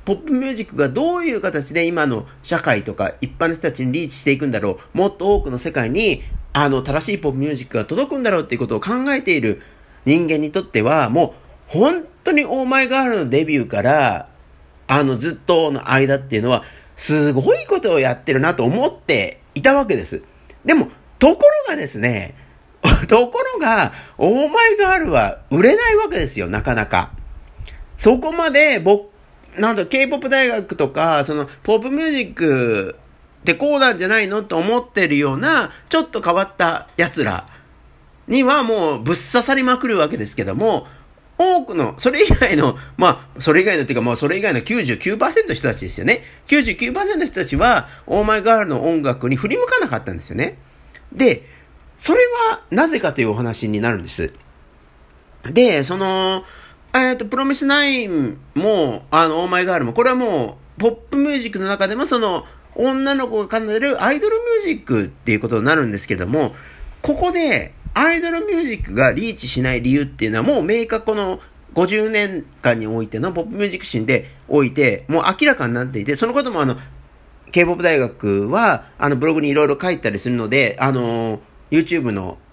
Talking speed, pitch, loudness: 370 characters per minute, 180 Hz, -17 LUFS